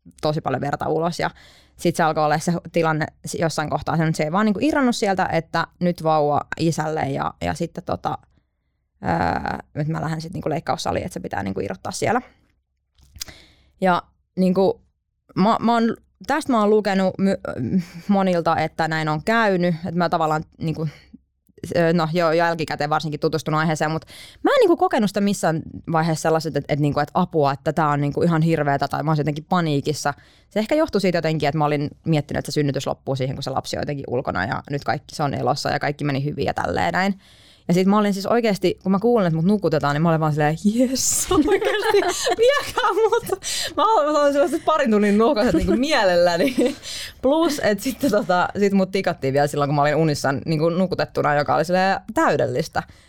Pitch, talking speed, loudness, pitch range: 165 Hz, 195 wpm, -21 LUFS, 150-200 Hz